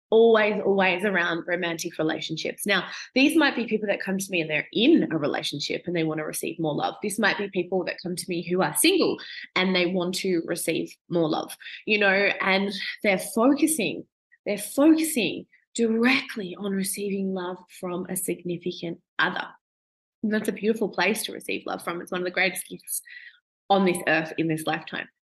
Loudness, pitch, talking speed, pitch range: -25 LUFS, 190 Hz, 190 wpm, 175-215 Hz